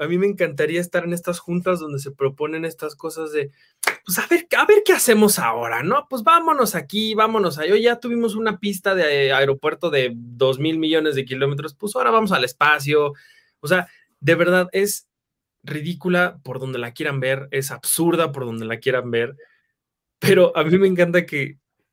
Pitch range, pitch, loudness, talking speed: 140-195 Hz, 165 Hz, -20 LUFS, 195 wpm